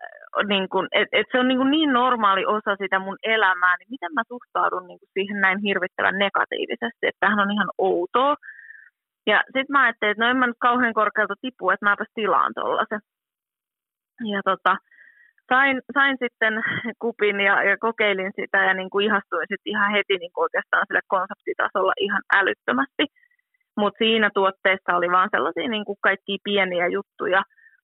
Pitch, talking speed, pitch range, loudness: 205 Hz, 170 wpm, 195-245 Hz, -21 LUFS